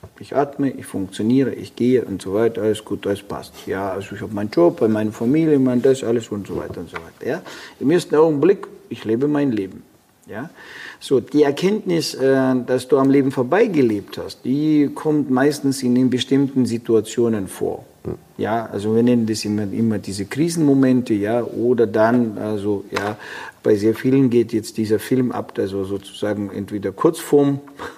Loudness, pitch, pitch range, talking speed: -19 LUFS, 120 Hz, 105-140 Hz, 180 wpm